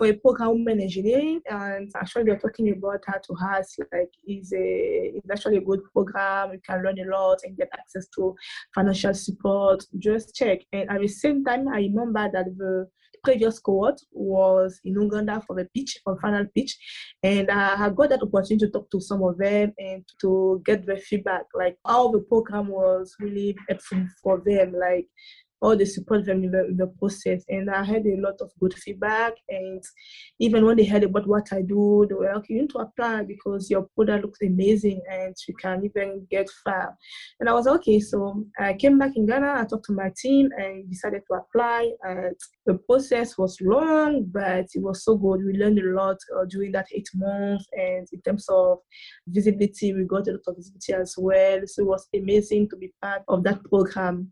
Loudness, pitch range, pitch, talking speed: -24 LUFS, 190-215 Hz, 200 Hz, 205 wpm